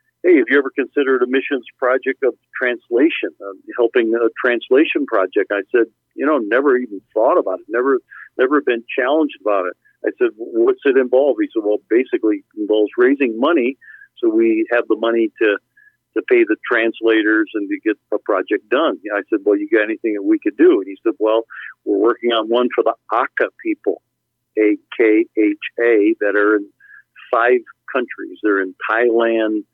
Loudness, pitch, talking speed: -17 LUFS, 335 Hz, 190 wpm